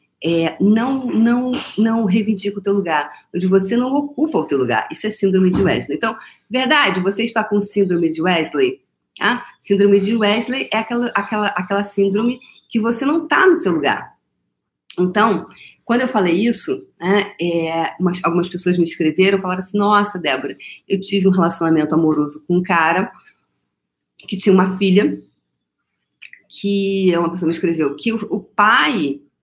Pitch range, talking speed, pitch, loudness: 175-225 Hz, 165 wpm, 200 Hz, -17 LUFS